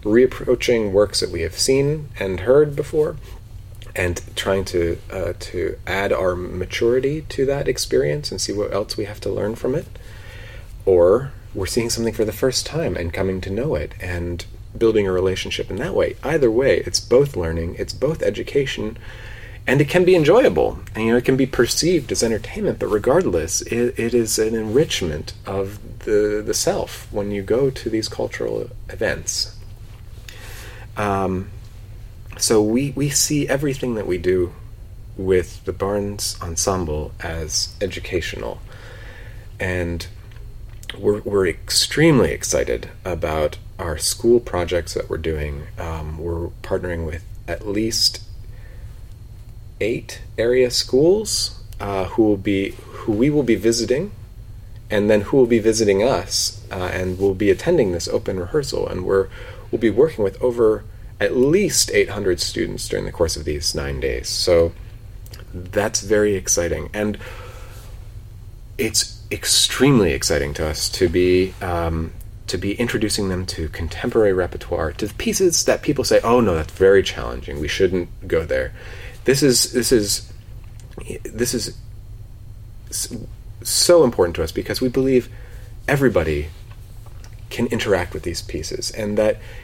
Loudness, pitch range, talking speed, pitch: -20 LUFS, 95-110 Hz, 150 wpm, 105 Hz